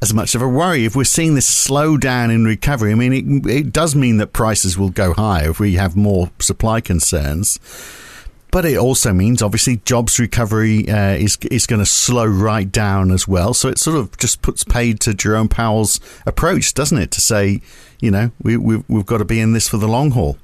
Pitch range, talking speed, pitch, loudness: 100-120 Hz, 225 wpm, 110 Hz, -15 LUFS